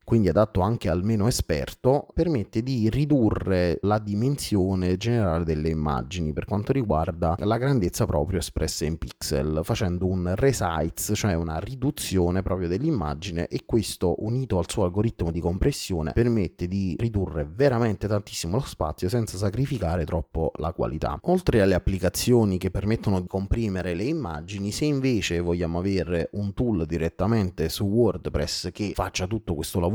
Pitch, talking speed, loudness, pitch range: 95 Hz, 150 wpm, -25 LUFS, 85-110 Hz